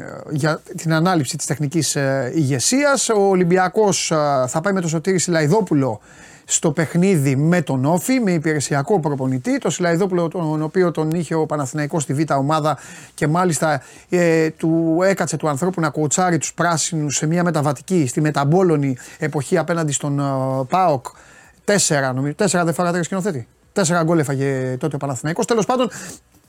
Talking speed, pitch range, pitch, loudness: 165 wpm, 145-180 Hz, 160 Hz, -19 LUFS